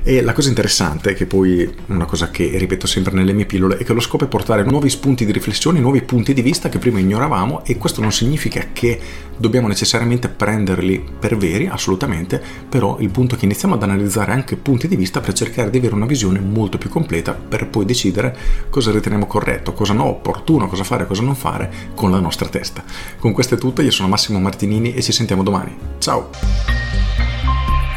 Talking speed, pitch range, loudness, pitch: 200 wpm, 95-125 Hz, -17 LUFS, 105 Hz